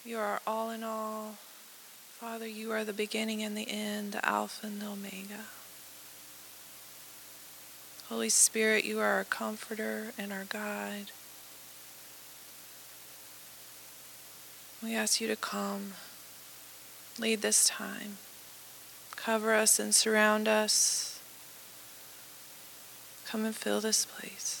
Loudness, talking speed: -30 LUFS, 110 wpm